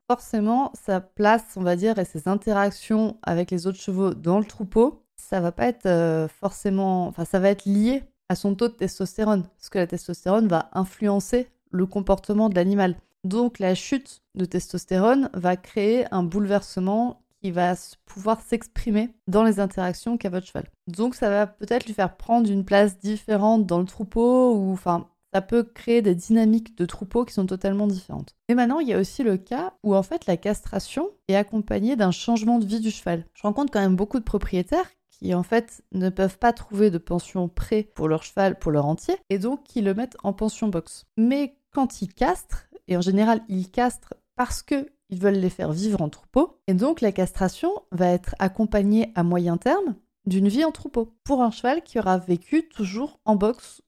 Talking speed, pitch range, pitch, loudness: 200 wpm, 185-235 Hz, 205 Hz, -24 LUFS